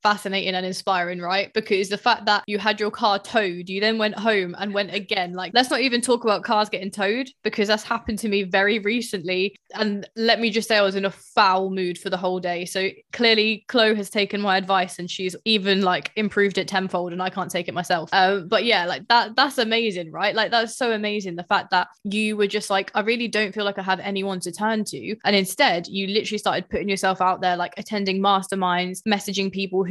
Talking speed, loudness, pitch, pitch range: 230 wpm, -22 LUFS, 200 Hz, 190-215 Hz